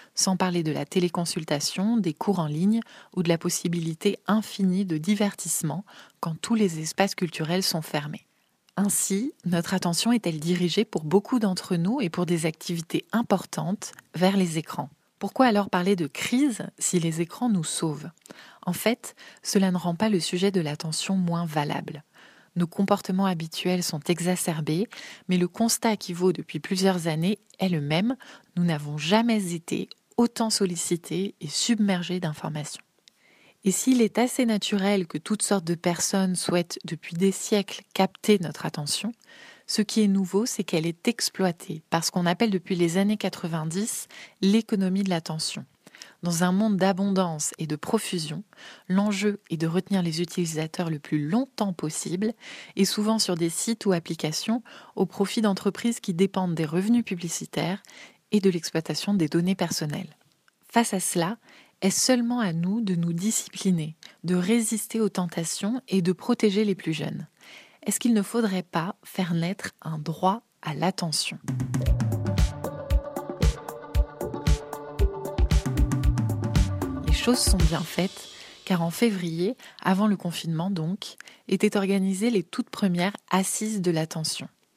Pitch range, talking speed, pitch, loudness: 170-205 Hz, 150 wpm, 185 Hz, -26 LUFS